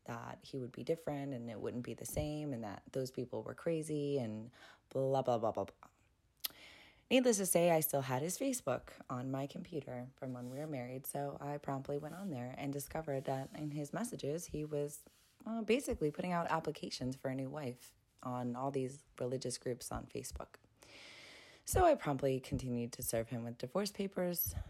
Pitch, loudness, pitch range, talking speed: 140 Hz, -39 LUFS, 125-155 Hz, 190 wpm